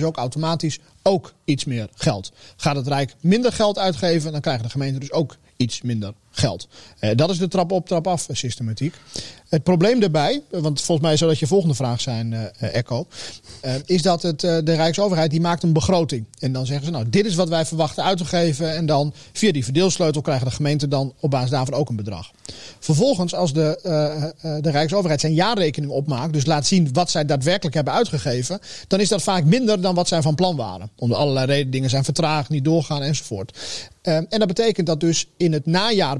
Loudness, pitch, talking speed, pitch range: -21 LUFS, 155 Hz, 205 wpm, 135-175 Hz